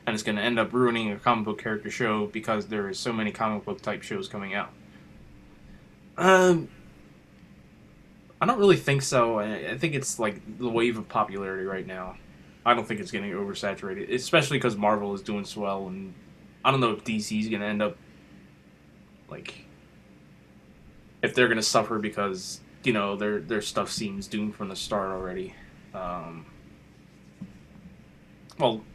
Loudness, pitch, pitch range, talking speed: -27 LUFS, 110 Hz, 100-125 Hz, 170 wpm